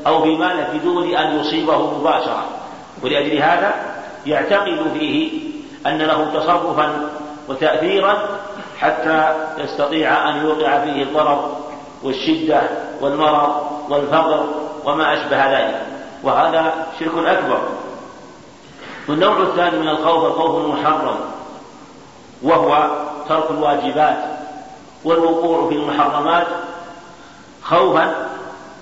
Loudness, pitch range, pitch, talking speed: -17 LUFS, 150-170 Hz, 155 Hz, 85 wpm